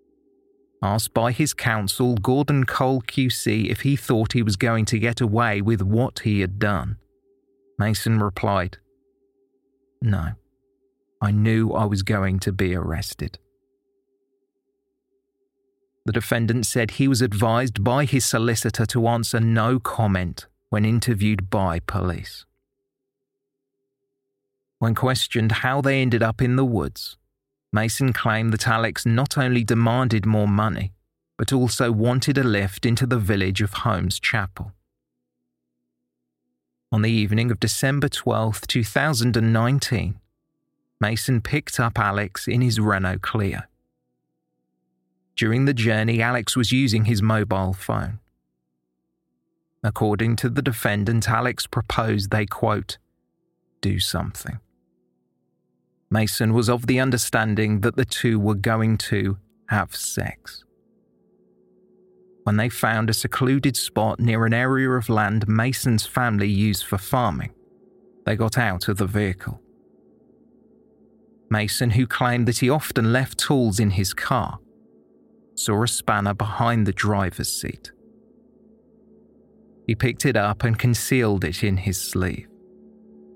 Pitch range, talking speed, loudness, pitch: 100-125 Hz, 125 wpm, -22 LUFS, 110 Hz